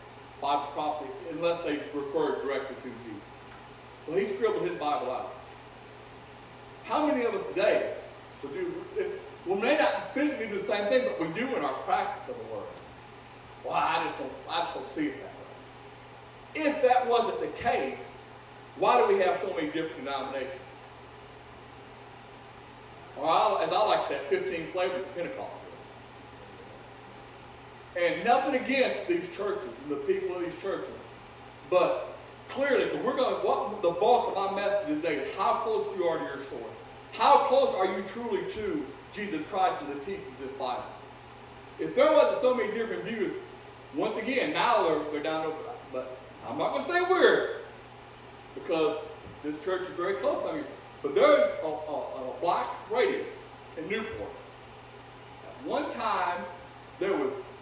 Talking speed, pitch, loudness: 165 wpm, 225 Hz, -29 LUFS